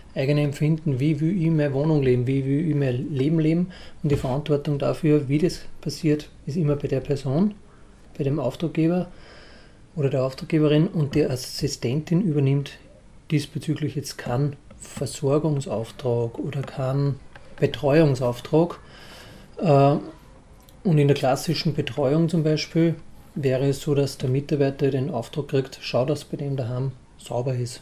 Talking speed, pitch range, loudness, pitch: 140 wpm, 135-155 Hz, -24 LUFS, 145 Hz